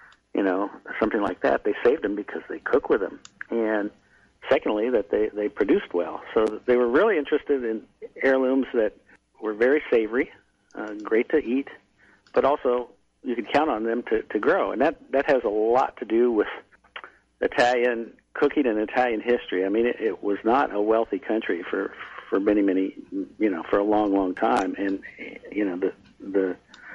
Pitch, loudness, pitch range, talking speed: 120 Hz, -24 LUFS, 105-150 Hz, 185 wpm